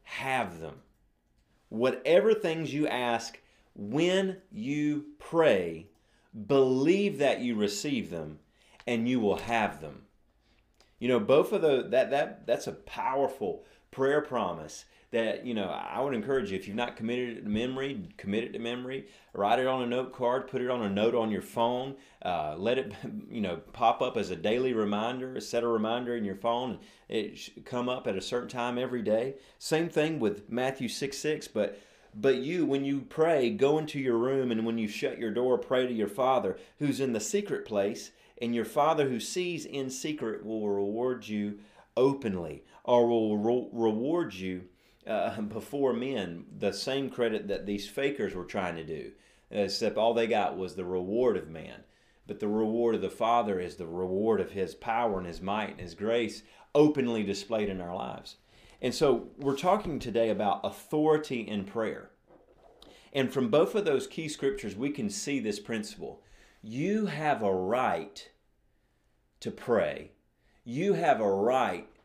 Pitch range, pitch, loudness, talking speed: 110-140 Hz, 125 Hz, -30 LUFS, 180 wpm